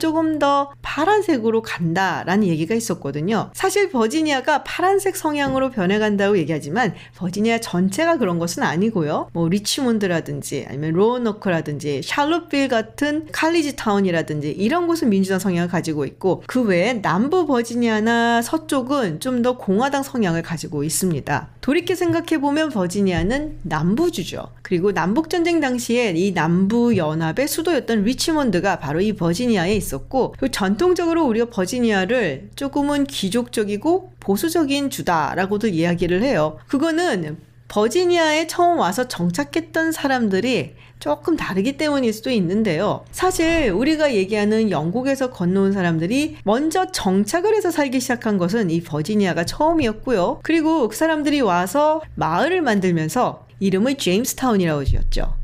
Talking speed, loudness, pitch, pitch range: 365 characters per minute, -20 LUFS, 225 Hz, 180-295 Hz